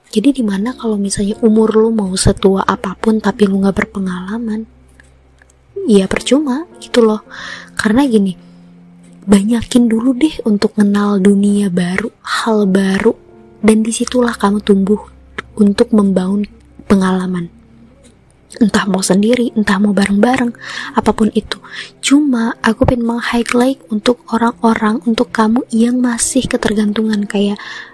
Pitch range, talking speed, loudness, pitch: 200-235 Hz, 120 wpm, -14 LUFS, 215 Hz